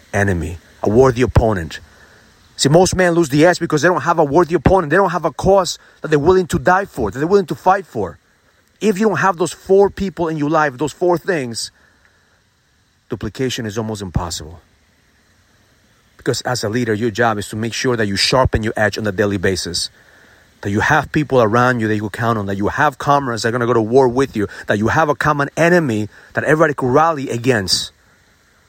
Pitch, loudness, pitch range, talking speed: 125 Hz, -16 LUFS, 105-165 Hz, 220 wpm